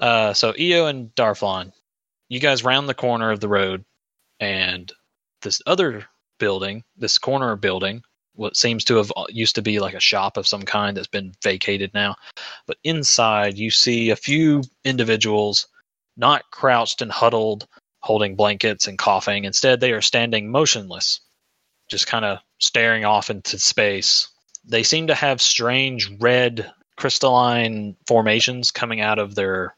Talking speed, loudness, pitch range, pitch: 155 wpm, -19 LUFS, 105-125 Hz, 110 Hz